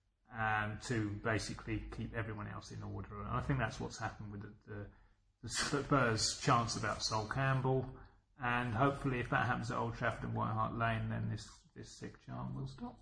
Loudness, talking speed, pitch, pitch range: -37 LUFS, 195 wpm, 110 Hz, 105-125 Hz